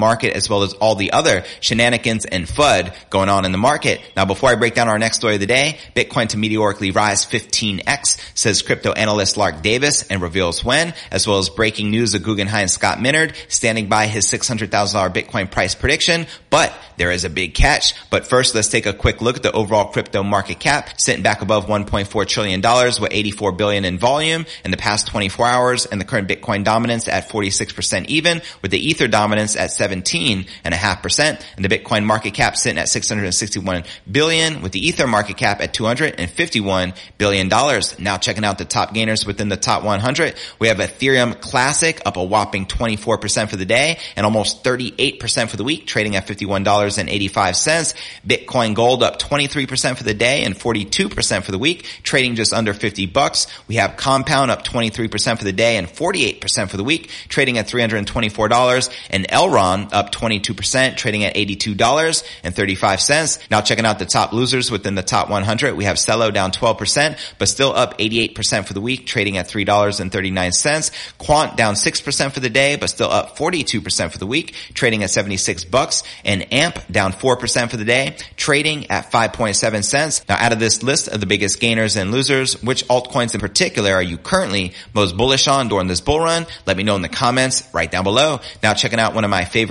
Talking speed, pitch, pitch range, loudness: 230 wpm, 110 Hz, 100-125 Hz, -17 LUFS